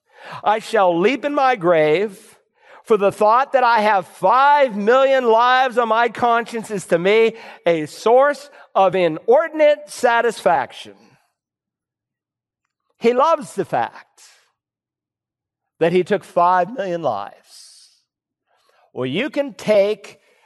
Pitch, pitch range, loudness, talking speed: 225 Hz, 195-265 Hz, -17 LUFS, 115 wpm